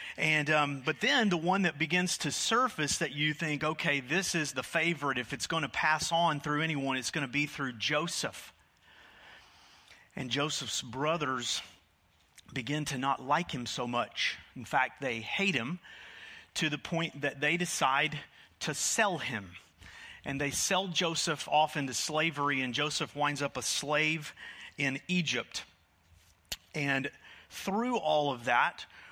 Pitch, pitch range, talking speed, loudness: 145 Hz, 130-160 Hz, 155 wpm, -31 LUFS